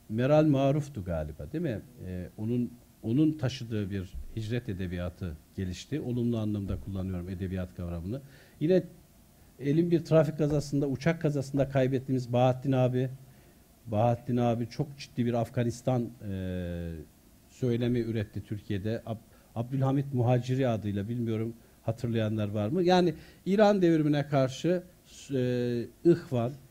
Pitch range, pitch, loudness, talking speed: 105-135 Hz, 120 Hz, -30 LUFS, 115 wpm